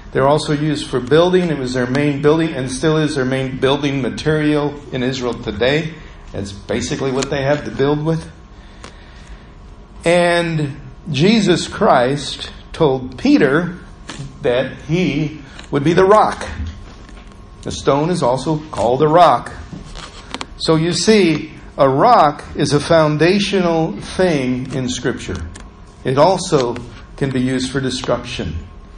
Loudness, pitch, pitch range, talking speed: -16 LUFS, 140 Hz, 120-155 Hz, 135 wpm